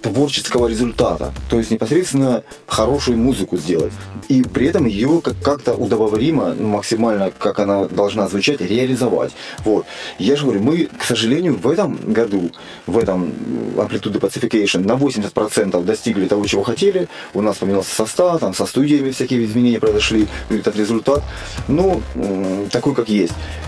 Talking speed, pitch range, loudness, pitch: 140 wpm, 100-125 Hz, -17 LUFS, 110 Hz